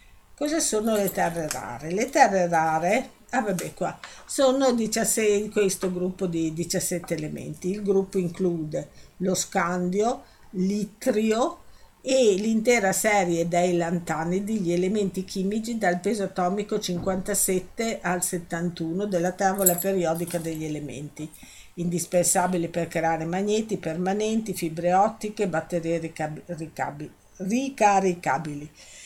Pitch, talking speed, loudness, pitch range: 185 Hz, 110 wpm, -25 LUFS, 170-205 Hz